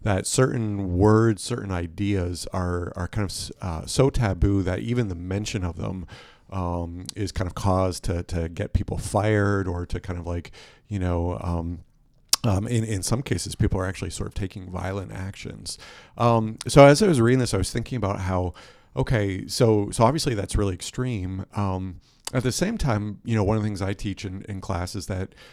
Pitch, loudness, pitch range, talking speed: 100 Hz, -25 LUFS, 95-115 Hz, 200 wpm